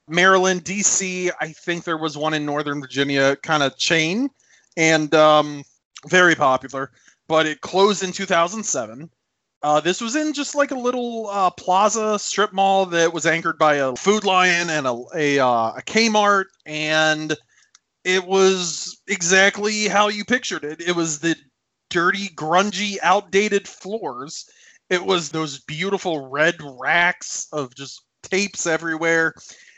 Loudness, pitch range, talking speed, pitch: -19 LUFS, 155-195 Hz, 145 wpm, 175 Hz